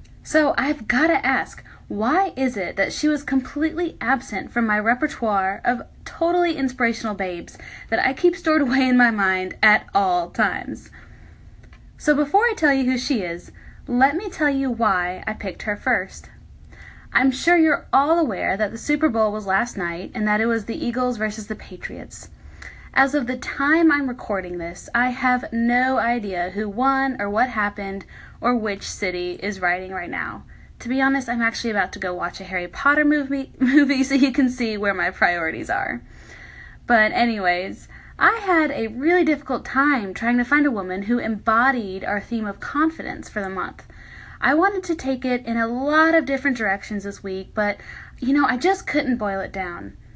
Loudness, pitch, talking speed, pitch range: -21 LUFS, 245 Hz, 190 wpm, 205-285 Hz